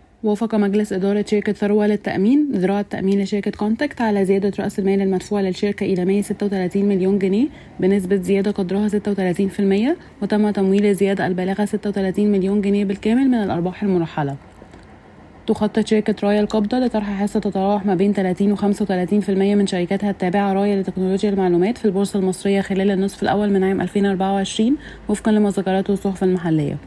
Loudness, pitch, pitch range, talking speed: -19 LUFS, 200 Hz, 195-210 Hz, 160 wpm